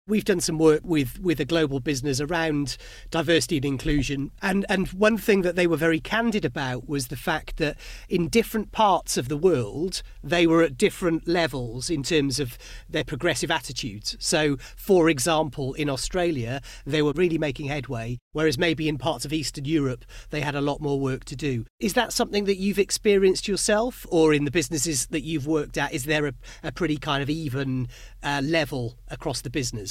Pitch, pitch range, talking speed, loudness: 155 Hz, 140-170 Hz, 195 wpm, -25 LUFS